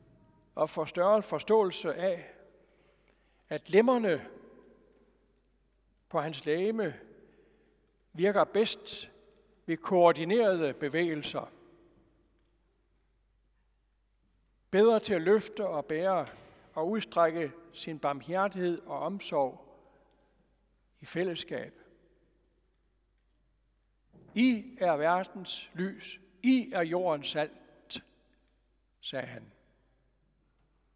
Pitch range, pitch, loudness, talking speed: 165-210 Hz, 185 Hz, -30 LUFS, 75 wpm